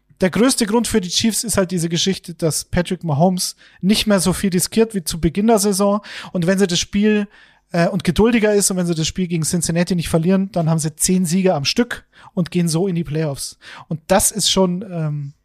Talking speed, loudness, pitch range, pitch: 230 wpm, -18 LUFS, 170-200 Hz, 185 Hz